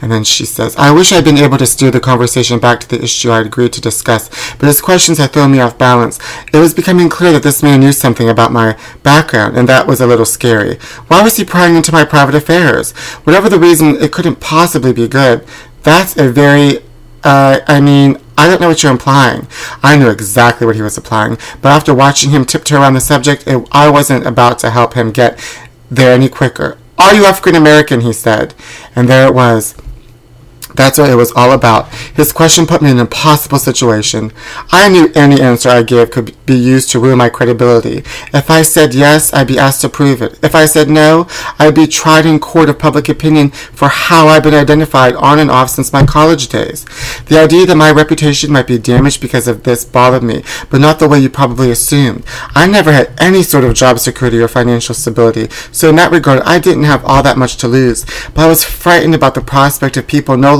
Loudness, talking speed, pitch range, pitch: -7 LUFS, 225 wpm, 120-155 Hz, 135 Hz